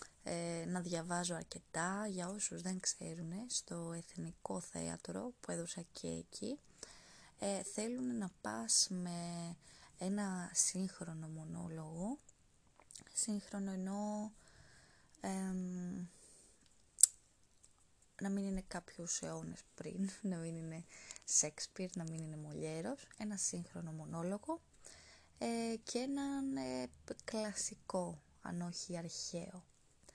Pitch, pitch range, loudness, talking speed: 180 Hz, 165-200 Hz, -41 LUFS, 100 wpm